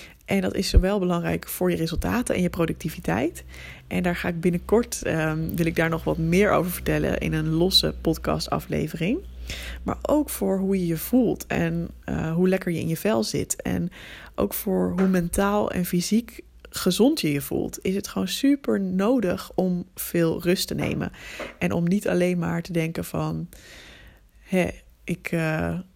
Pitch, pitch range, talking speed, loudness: 175 Hz, 160-190 Hz, 180 wpm, -24 LUFS